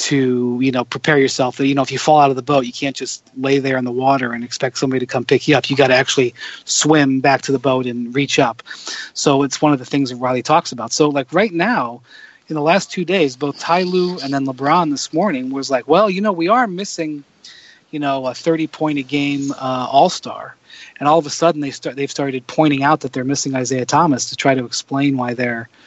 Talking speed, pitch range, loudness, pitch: 250 wpm, 130-150 Hz, -17 LUFS, 140 Hz